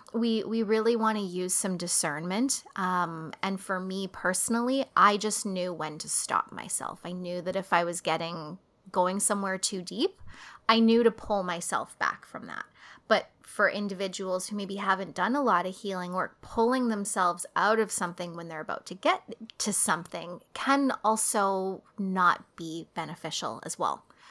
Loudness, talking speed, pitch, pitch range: -28 LUFS, 175 wpm, 190 Hz, 180-220 Hz